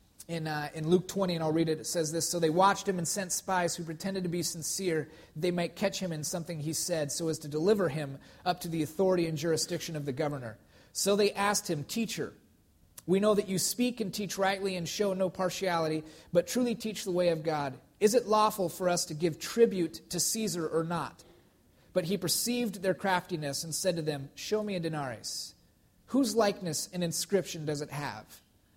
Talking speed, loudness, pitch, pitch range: 215 wpm, -31 LUFS, 175 Hz, 155-195 Hz